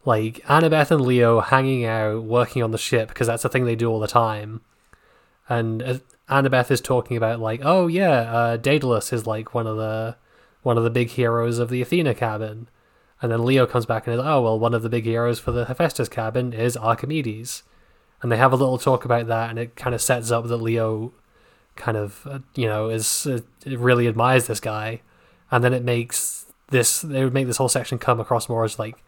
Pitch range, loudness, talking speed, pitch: 115-130 Hz, -21 LUFS, 220 wpm, 120 Hz